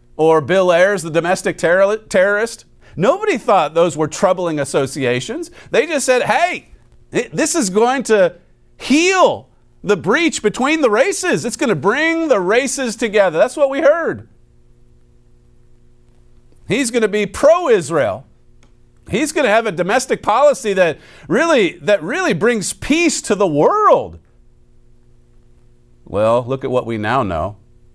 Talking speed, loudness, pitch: 145 wpm, -15 LUFS, 205 Hz